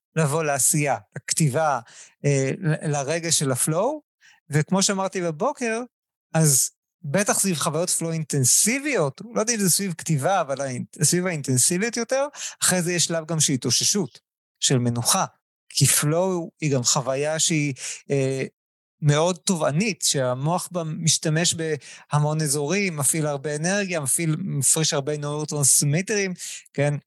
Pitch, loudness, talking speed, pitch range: 160 Hz, -22 LUFS, 125 wpm, 145-180 Hz